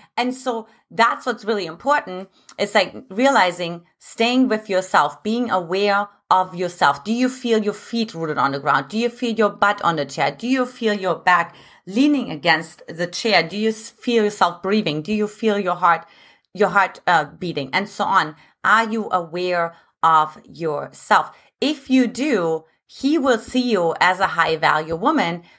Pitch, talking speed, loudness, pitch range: 205 Hz, 180 wpm, -20 LUFS, 170-230 Hz